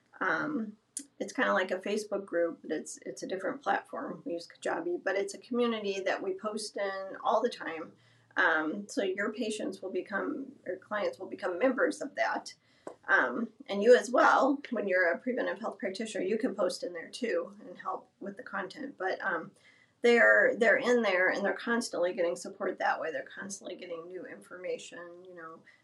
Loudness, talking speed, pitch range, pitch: -31 LUFS, 195 wpm, 185-245 Hz, 205 Hz